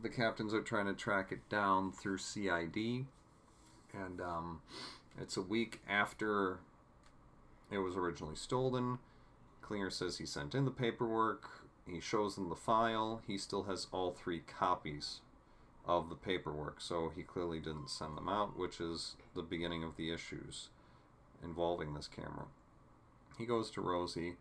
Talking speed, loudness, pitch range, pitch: 150 wpm, -40 LUFS, 85-110 Hz, 95 Hz